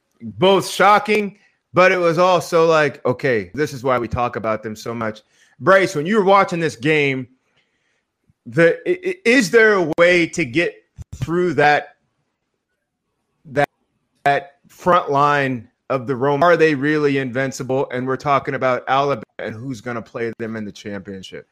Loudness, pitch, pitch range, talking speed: -17 LUFS, 145 Hz, 125-180 Hz, 160 wpm